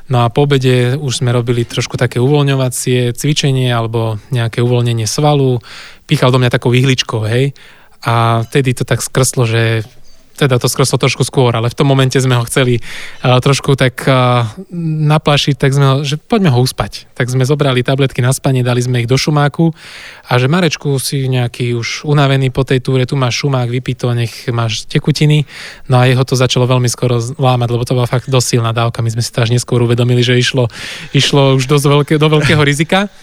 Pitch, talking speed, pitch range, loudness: 130 Hz, 200 wpm, 120-140 Hz, -13 LUFS